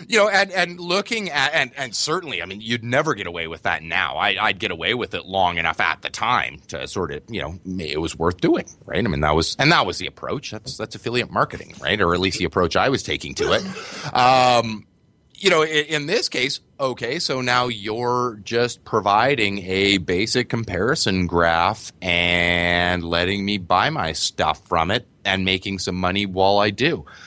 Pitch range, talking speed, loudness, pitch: 90-125 Hz, 210 wpm, -20 LUFS, 100 Hz